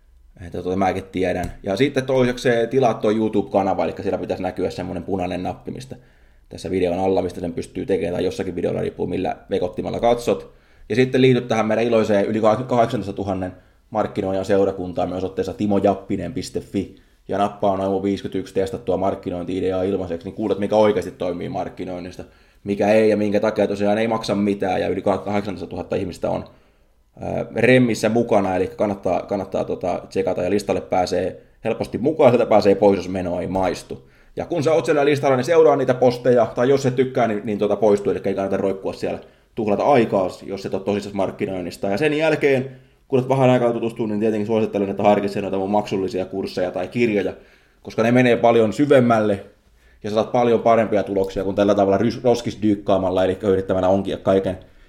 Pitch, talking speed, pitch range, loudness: 100 Hz, 175 wpm, 95-115 Hz, -20 LUFS